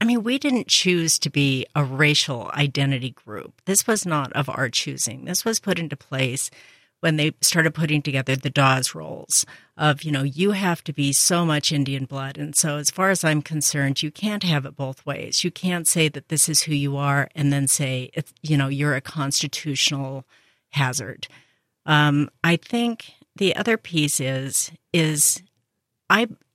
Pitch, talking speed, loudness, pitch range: 150 Hz, 185 wpm, -21 LUFS, 135-165 Hz